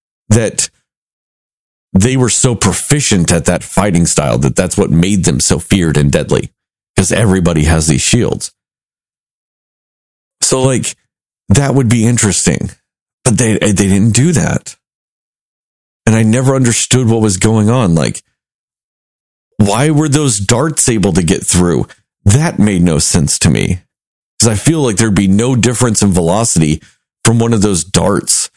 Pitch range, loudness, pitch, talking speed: 95-125 Hz, -11 LUFS, 110 Hz, 155 wpm